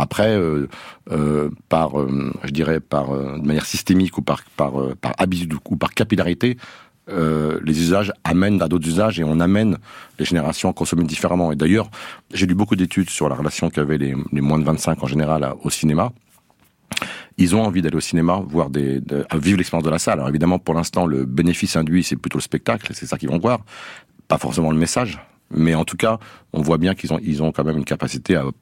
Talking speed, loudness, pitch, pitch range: 225 wpm, -20 LUFS, 80 Hz, 75-90 Hz